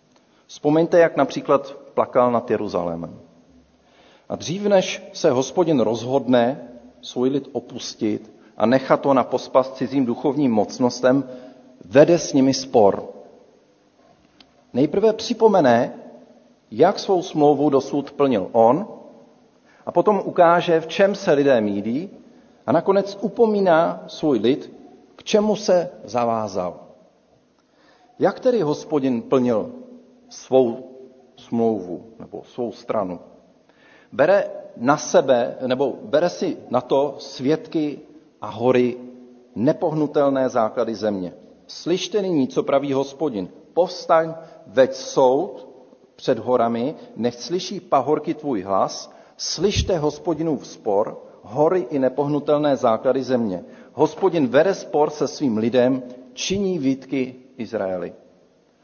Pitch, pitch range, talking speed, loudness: 140 Hz, 125-175 Hz, 110 wpm, -20 LUFS